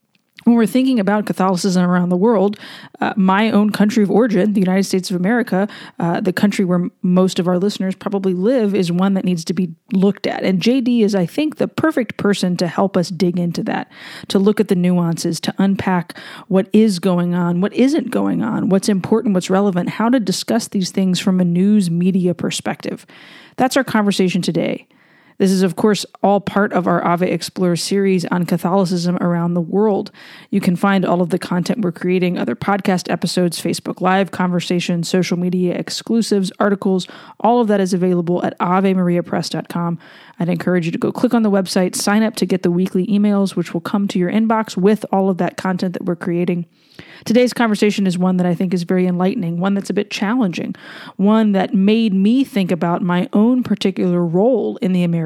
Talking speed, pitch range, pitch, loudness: 200 wpm, 180-210 Hz, 190 Hz, -17 LUFS